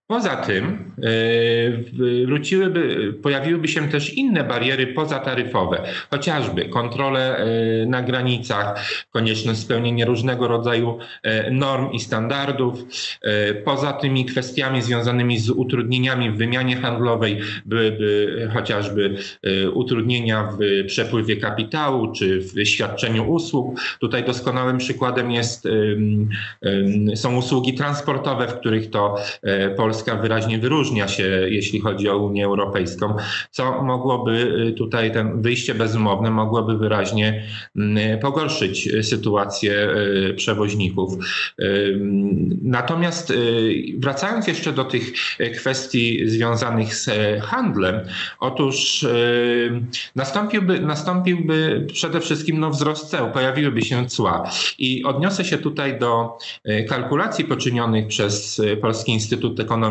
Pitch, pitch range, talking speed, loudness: 120 Hz, 110-130 Hz, 100 wpm, -20 LUFS